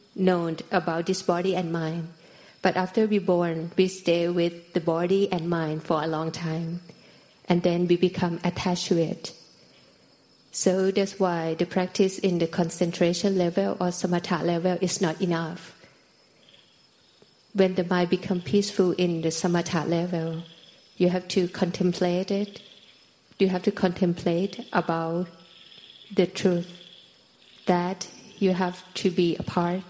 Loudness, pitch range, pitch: -26 LUFS, 170-185 Hz, 180 Hz